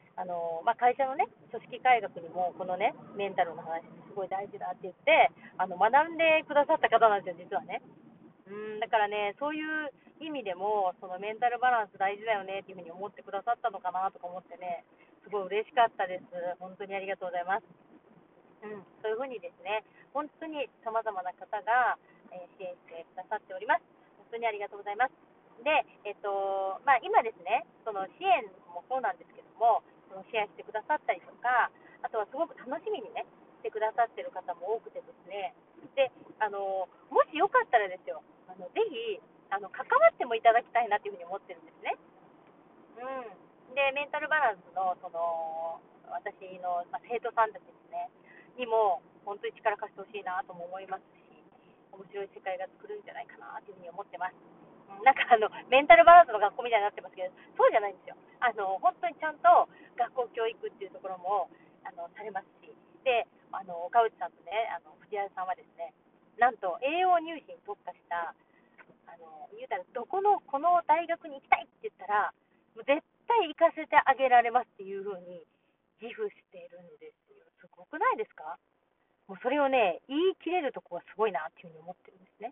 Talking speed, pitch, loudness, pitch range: 390 characters per minute, 215 Hz, -30 LUFS, 185-290 Hz